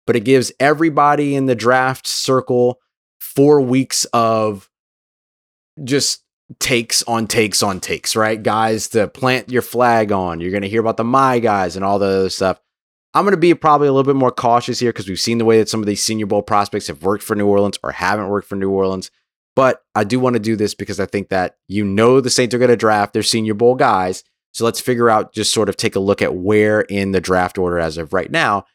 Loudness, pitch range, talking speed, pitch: -16 LUFS, 100-125 Hz, 240 wpm, 110 Hz